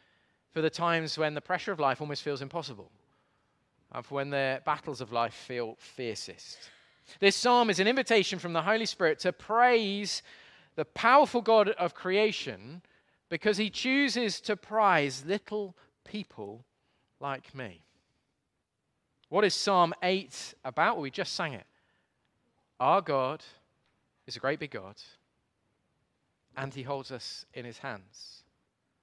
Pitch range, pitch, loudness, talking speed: 140-210 Hz, 170 Hz, -29 LUFS, 145 wpm